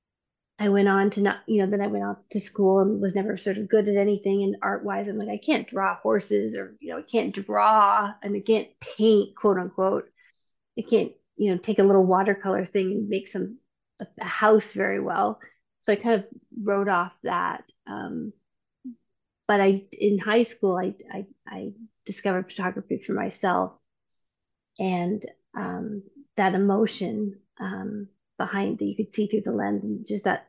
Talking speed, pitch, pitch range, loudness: 190 wpm, 205 Hz, 195-215 Hz, -25 LUFS